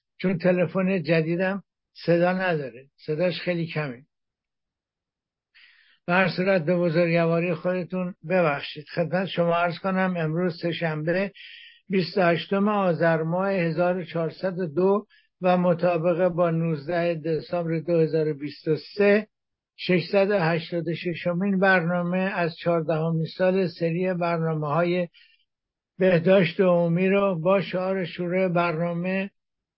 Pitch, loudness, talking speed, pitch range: 175 Hz, -24 LUFS, 95 wpm, 165-190 Hz